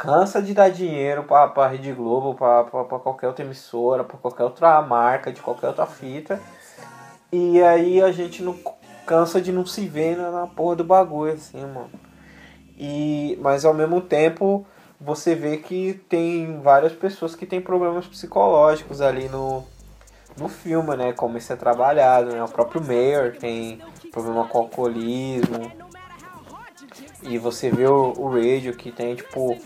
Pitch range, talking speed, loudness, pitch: 125-175 Hz, 160 wpm, -21 LUFS, 145 Hz